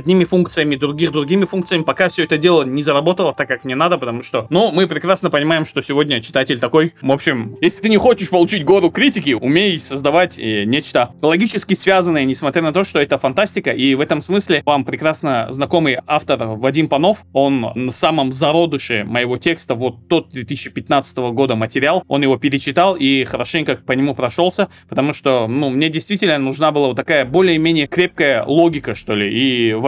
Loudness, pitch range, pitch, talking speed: -16 LUFS, 135-175 Hz, 150 Hz, 180 wpm